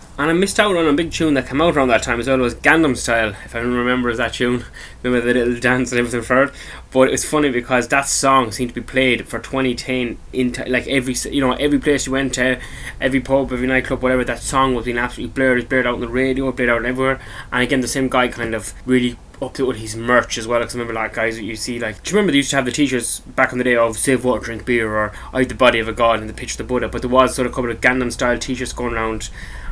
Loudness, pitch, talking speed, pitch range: -18 LUFS, 125 Hz, 295 wpm, 120-130 Hz